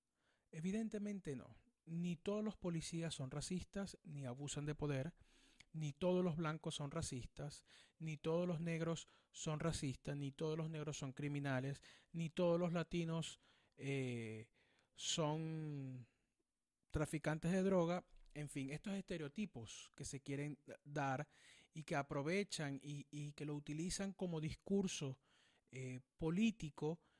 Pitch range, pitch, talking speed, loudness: 140-170 Hz, 155 Hz, 130 wpm, -45 LUFS